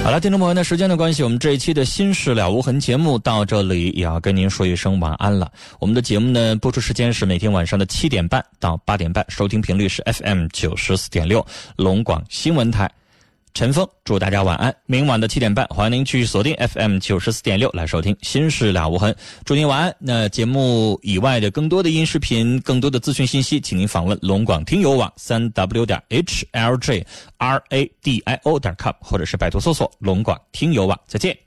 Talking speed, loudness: 330 characters per minute, -19 LUFS